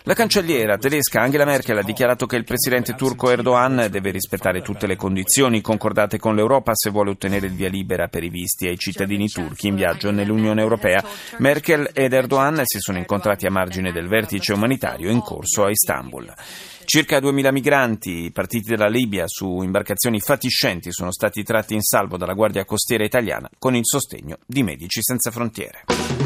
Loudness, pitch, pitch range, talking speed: -20 LUFS, 110 Hz, 95-125 Hz, 175 wpm